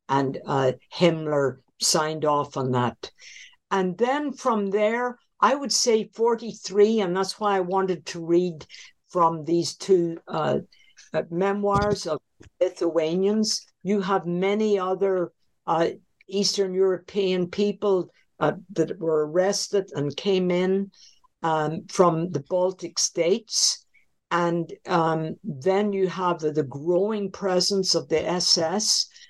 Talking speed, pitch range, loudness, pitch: 125 wpm, 165-200 Hz, -24 LUFS, 185 Hz